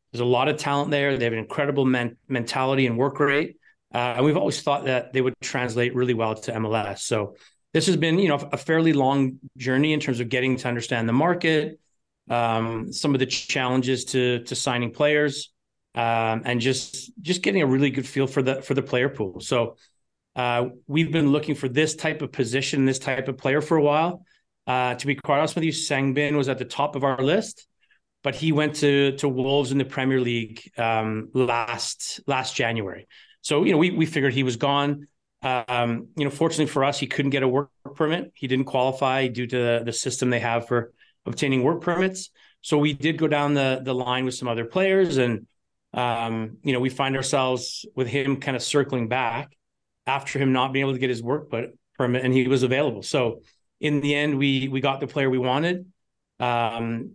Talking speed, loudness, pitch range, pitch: 210 wpm, -24 LUFS, 125-145 Hz, 135 Hz